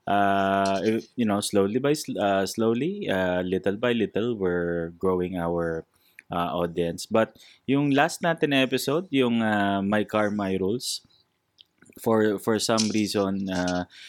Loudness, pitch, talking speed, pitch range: -25 LUFS, 100 Hz, 140 wpm, 95-115 Hz